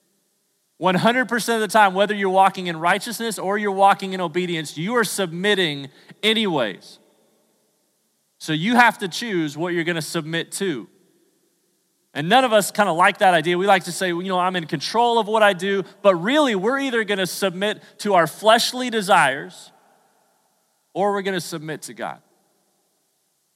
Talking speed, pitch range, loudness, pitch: 175 wpm, 175-215 Hz, -20 LUFS, 195 Hz